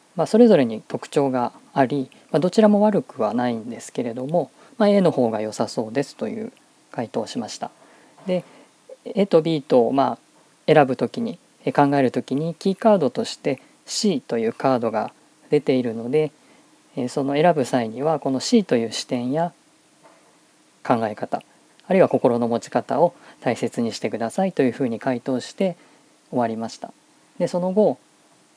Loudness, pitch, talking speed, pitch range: -22 LUFS, 155 Hz, 315 characters per minute, 130-205 Hz